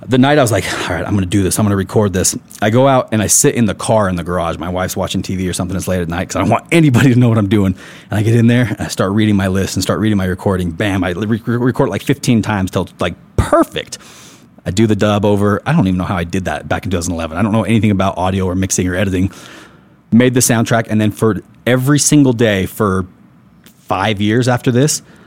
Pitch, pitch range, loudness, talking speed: 105 Hz, 95-115 Hz, -14 LUFS, 275 wpm